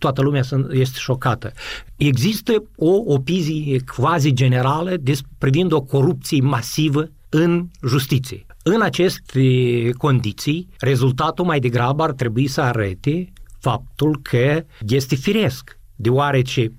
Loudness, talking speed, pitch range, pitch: -19 LUFS, 110 wpm, 125-155 Hz, 135 Hz